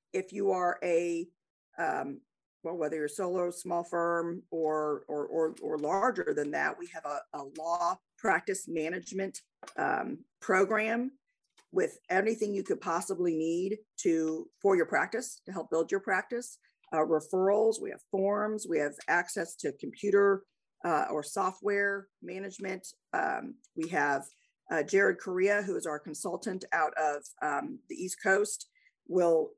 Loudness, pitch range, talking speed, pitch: -32 LUFS, 170-220 Hz, 150 wpm, 190 Hz